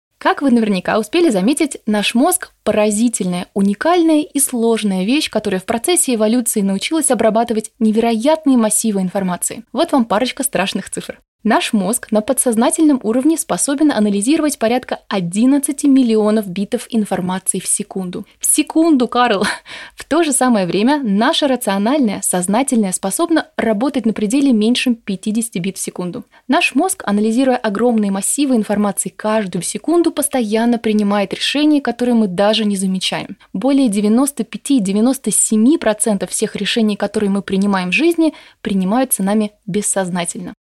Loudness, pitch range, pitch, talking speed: -15 LUFS, 205-270 Hz, 225 Hz, 130 wpm